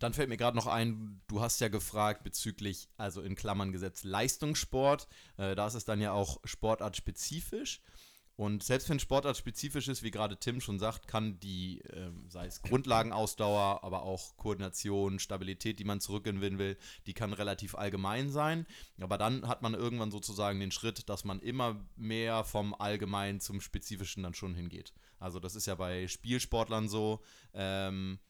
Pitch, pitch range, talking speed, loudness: 105 Hz, 95-115 Hz, 175 wpm, -36 LUFS